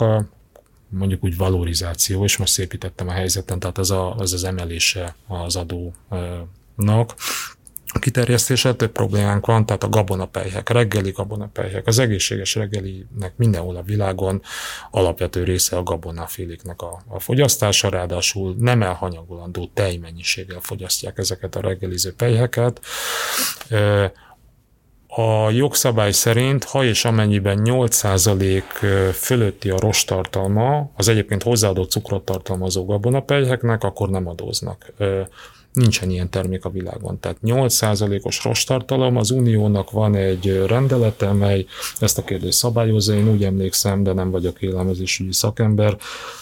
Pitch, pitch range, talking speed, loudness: 100 Hz, 95-115 Hz, 125 wpm, -19 LUFS